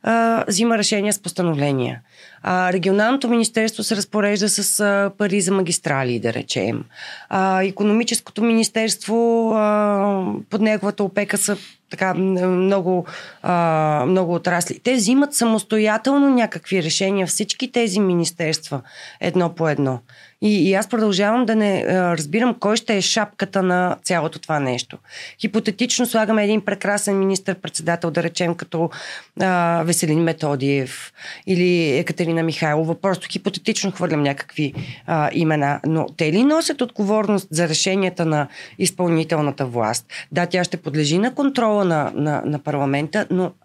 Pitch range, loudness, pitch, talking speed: 165-210 Hz, -19 LUFS, 190 Hz, 135 wpm